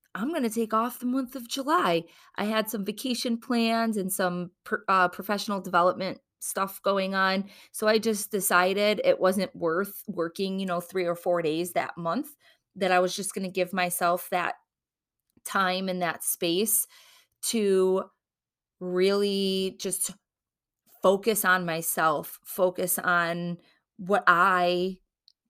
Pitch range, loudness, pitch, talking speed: 180-215 Hz, -27 LUFS, 190 Hz, 145 wpm